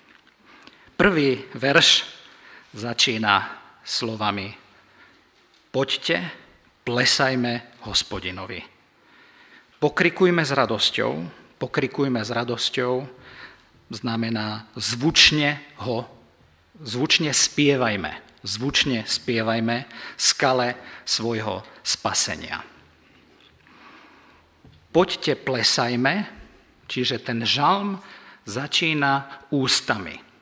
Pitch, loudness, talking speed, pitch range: 125 Hz, -22 LUFS, 60 wpm, 115-140 Hz